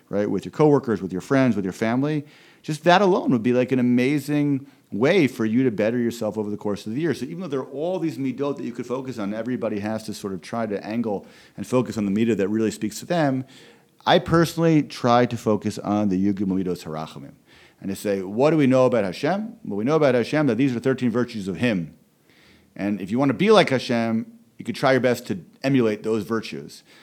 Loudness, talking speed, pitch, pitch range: -22 LUFS, 240 wpm, 125 Hz, 105-140 Hz